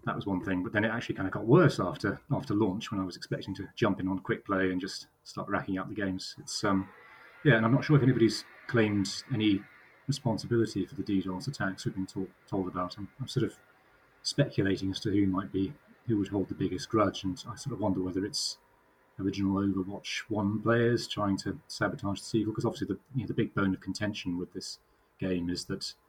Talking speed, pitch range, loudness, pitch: 230 wpm, 95-110 Hz, -31 LUFS, 100 Hz